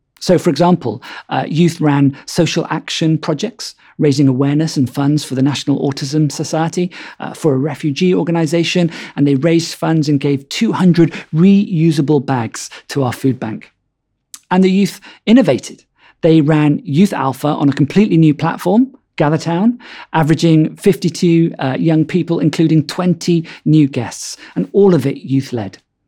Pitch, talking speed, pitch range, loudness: 160 Hz, 150 wpm, 145-175 Hz, -14 LUFS